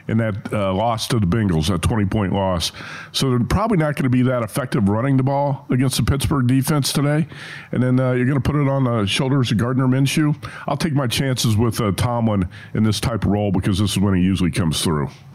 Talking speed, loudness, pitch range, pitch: 240 wpm, -19 LUFS, 105-135 Hz, 125 Hz